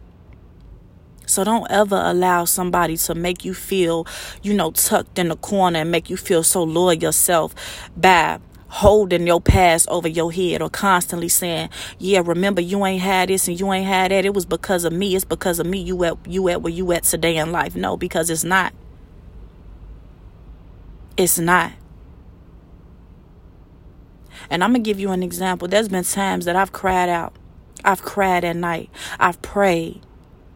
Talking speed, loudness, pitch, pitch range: 175 wpm, -18 LUFS, 175 Hz, 165-190 Hz